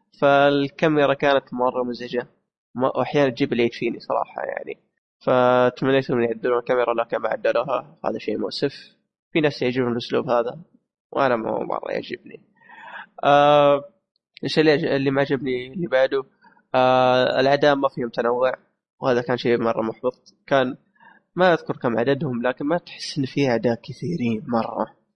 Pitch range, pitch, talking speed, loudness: 125-145 Hz, 130 Hz, 140 wpm, -21 LUFS